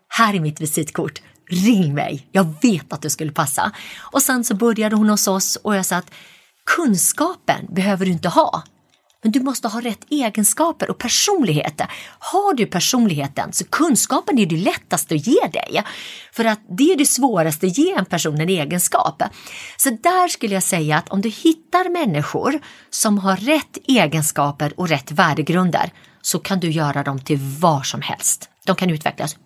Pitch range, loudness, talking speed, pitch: 165-245 Hz, -18 LUFS, 180 wpm, 195 Hz